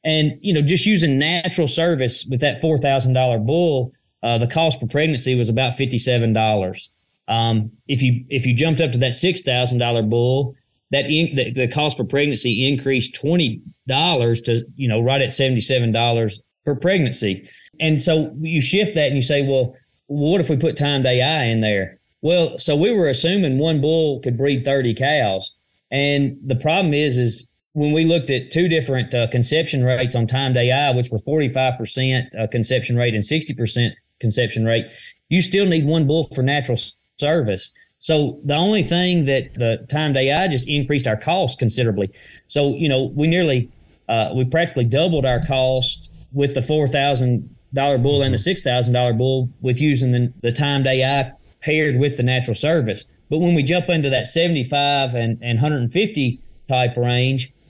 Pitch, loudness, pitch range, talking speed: 135 Hz, -19 LUFS, 120-150 Hz, 180 wpm